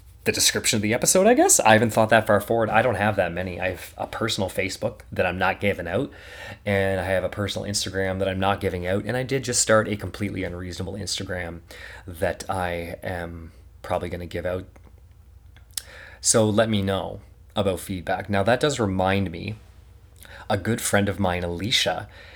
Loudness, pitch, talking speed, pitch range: -23 LUFS, 95 Hz, 195 wpm, 90-105 Hz